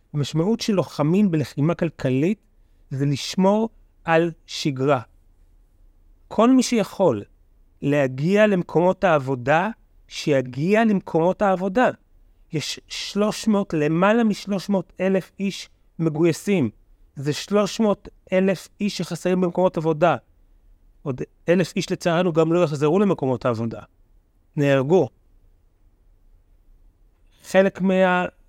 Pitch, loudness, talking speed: 160 Hz, -21 LUFS, 90 wpm